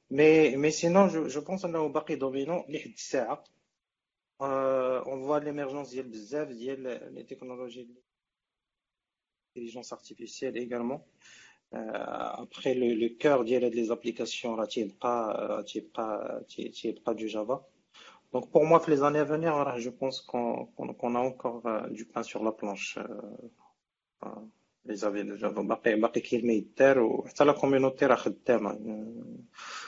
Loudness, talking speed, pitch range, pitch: -29 LUFS, 120 wpm, 115-145 Hz, 125 Hz